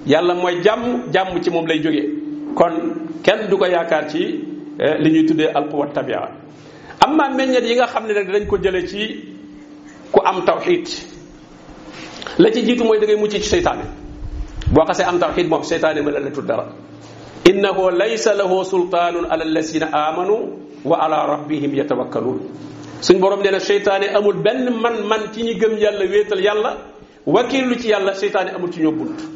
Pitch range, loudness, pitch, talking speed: 165-230 Hz, -18 LUFS, 200 Hz, 175 wpm